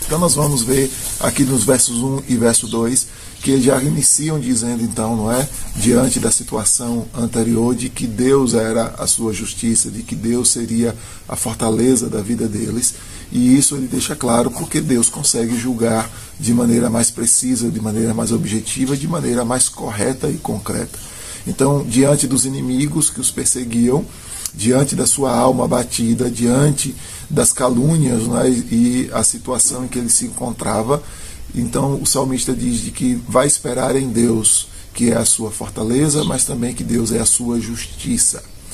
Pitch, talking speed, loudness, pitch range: 120 Hz, 165 wpm, -16 LUFS, 115-130 Hz